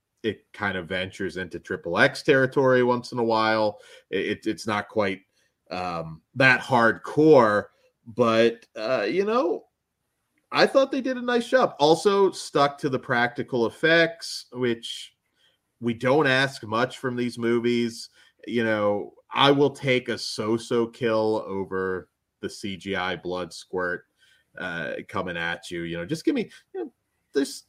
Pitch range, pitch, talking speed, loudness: 105-140 Hz, 120 Hz, 150 wpm, -24 LUFS